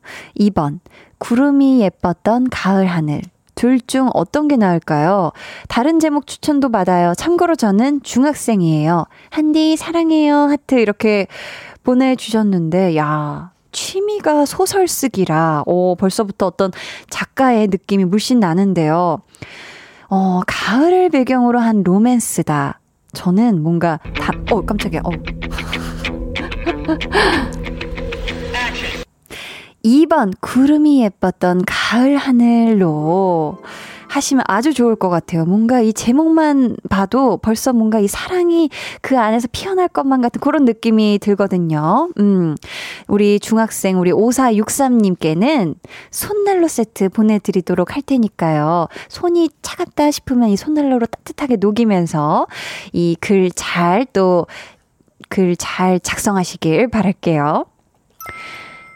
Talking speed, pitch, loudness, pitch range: 235 characters per minute, 215 Hz, -15 LUFS, 180-265 Hz